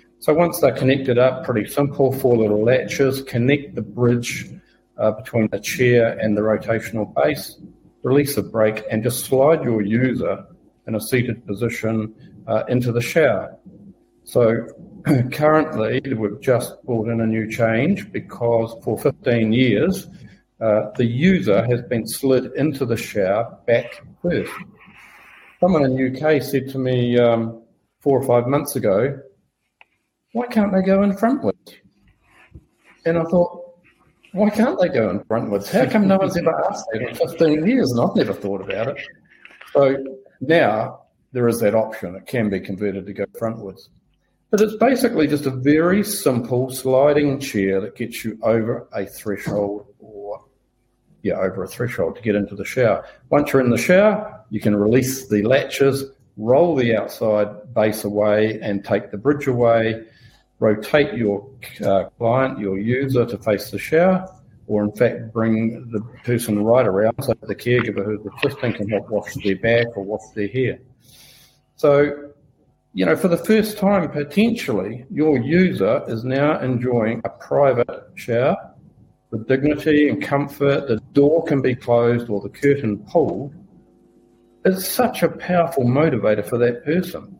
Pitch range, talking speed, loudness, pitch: 110-145 Hz, 160 wpm, -19 LUFS, 125 Hz